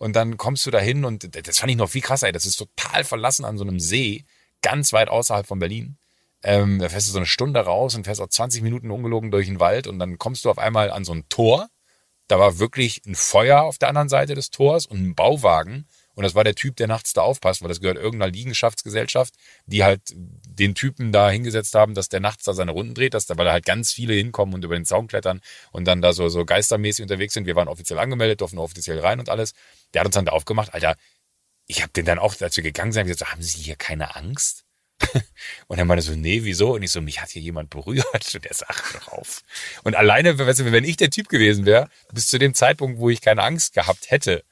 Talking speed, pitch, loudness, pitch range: 250 wpm, 105 Hz, -20 LUFS, 95-120 Hz